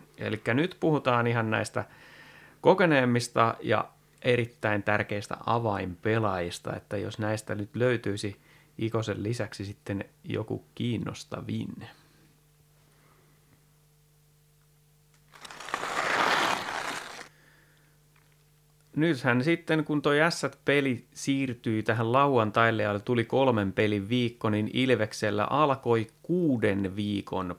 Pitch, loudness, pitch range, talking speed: 120 Hz, -28 LUFS, 105-150 Hz, 85 wpm